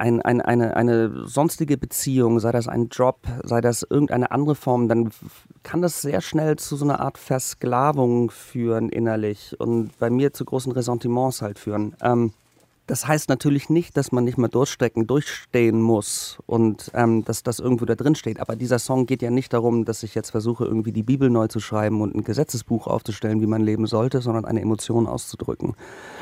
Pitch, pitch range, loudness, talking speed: 120 Hz, 115-130 Hz, -22 LUFS, 190 wpm